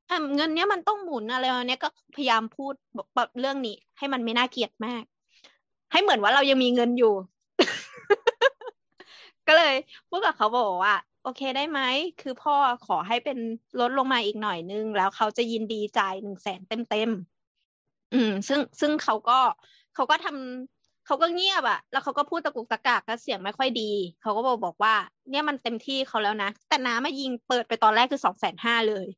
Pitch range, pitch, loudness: 220-285 Hz, 250 Hz, -25 LUFS